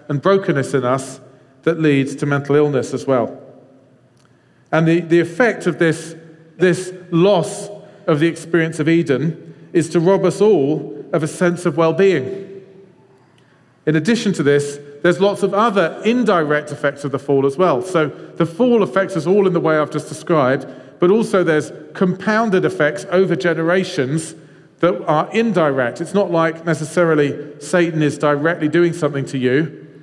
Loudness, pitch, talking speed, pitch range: -17 LUFS, 165 Hz, 165 wpm, 145-185 Hz